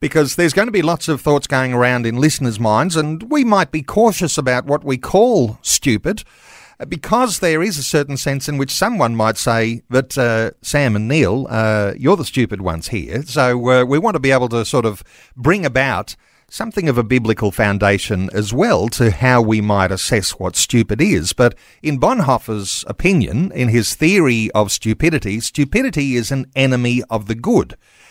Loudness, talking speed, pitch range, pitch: -16 LUFS, 190 wpm, 110-150 Hz, 125 Hz